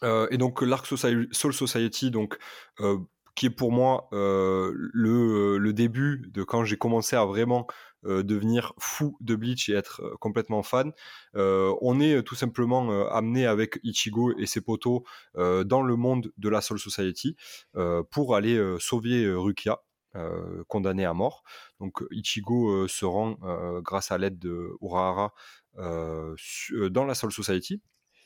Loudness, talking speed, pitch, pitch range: -27 LUFS, 170 wpm, 110 Hz, 95-125 Hz